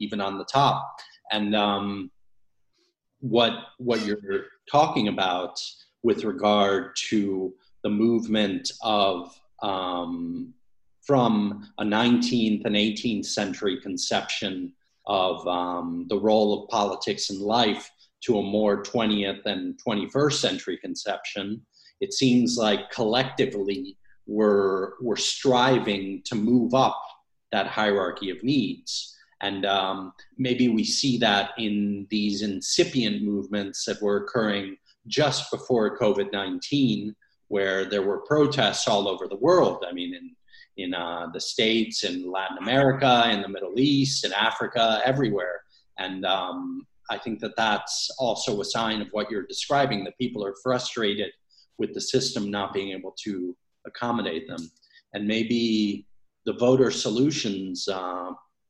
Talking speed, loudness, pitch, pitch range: 130 wpm, -25 LUFS, 105 Hz, 100-125 Hz